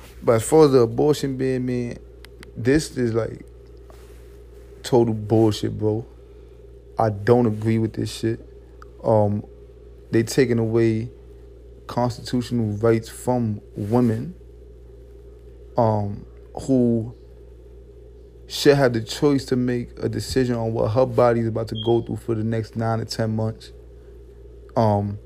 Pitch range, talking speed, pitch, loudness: 110-125 Hz, 130 wpm, 115 Hz, -22 LUFS